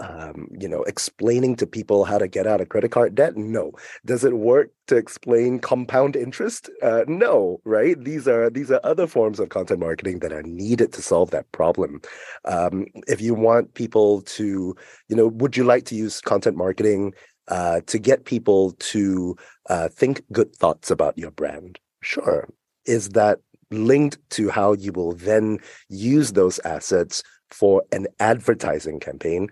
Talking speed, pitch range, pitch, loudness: 170 wpm, 100-125 Hz, 110 Hz, -21 LUFS